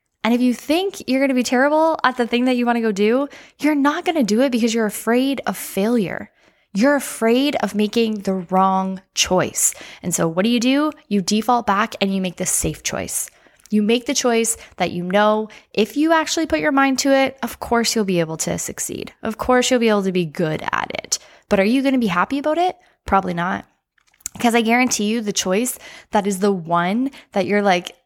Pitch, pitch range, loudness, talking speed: 230 Hz, 200-270 Hz, -19 LUFS, 220 wpm